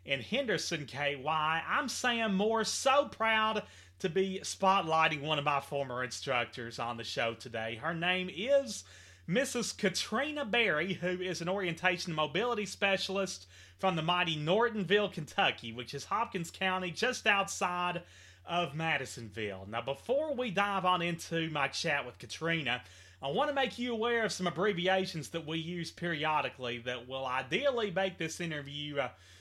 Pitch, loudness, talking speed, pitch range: 170 Hz, -33 LUFS, 155 wpm, 140-195 Hz